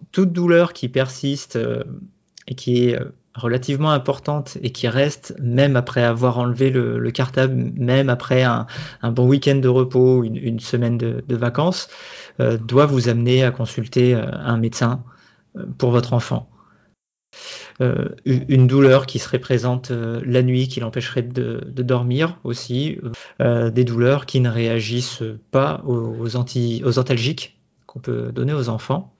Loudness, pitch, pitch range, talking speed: -19 LUFS, 125 Hz, 120-135 Hz, 155 wpm